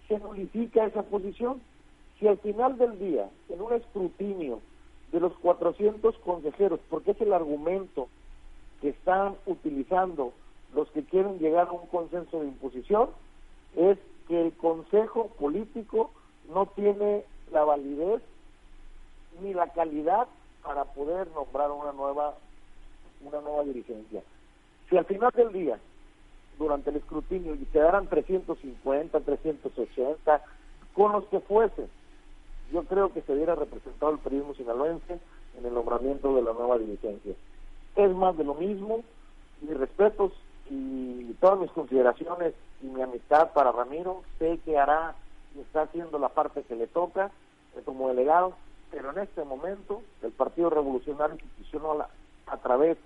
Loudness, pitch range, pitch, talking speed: -28 LUFS, 145-195 Hz, 165 Hz, 140 wpm